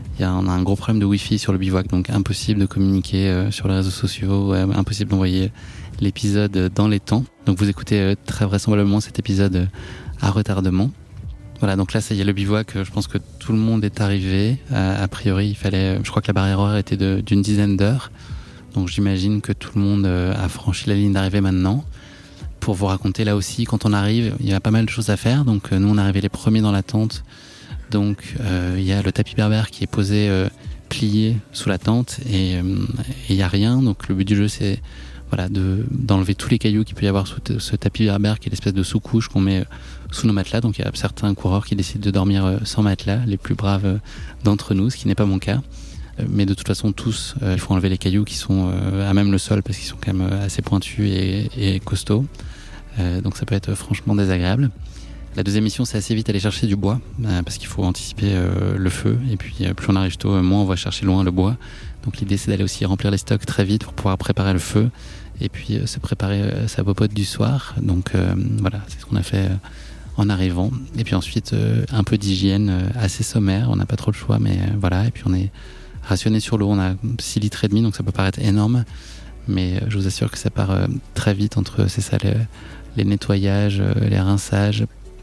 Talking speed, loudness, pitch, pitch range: 235 wpm, -20 LUFS, 100 Hz, 95-110 Hz